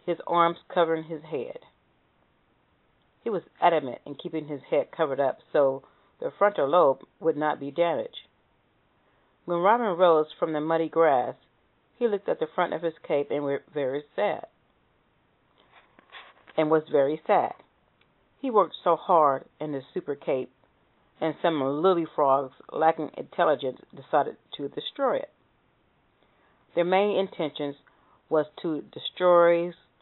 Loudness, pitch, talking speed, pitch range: -26 LUFS, 165 Hz, 140 wpm, 150-180 Hz